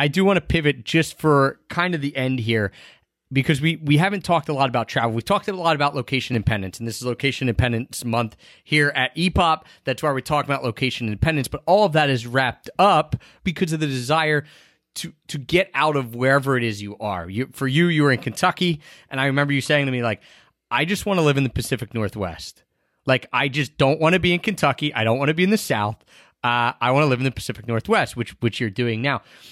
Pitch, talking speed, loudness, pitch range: 135 Hz, 245 wpm, -21 LUFS, 120-155 Hz